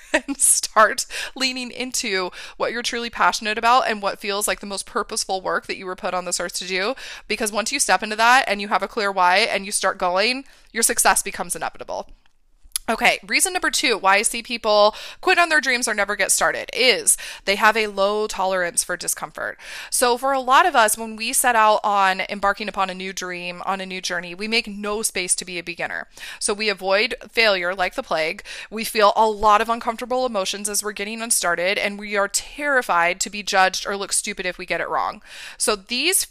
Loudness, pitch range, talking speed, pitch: -20 LUFS, 190-240 Hz, 220 wpm, 210 Hz